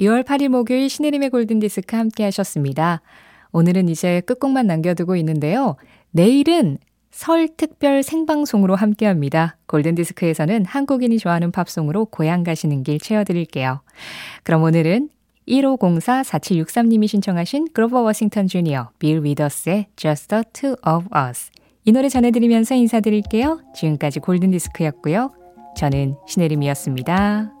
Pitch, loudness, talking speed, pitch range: 195 Hz, -18 LUFS, 350 characters per minute, 160-240 Hz